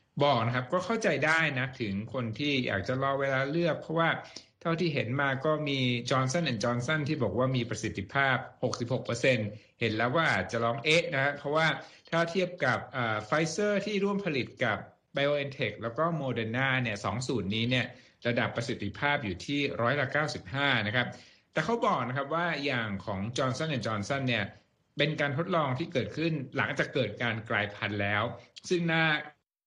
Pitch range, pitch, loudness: 115-155 Hz, 130 Hz, -30 LUFS